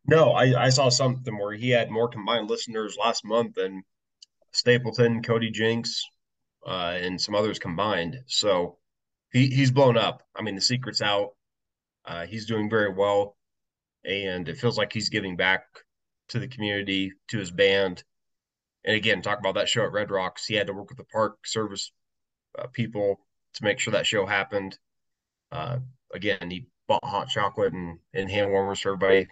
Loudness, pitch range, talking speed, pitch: -25 LUFS, 95-120 Hz, 180 wpm, 105 Hz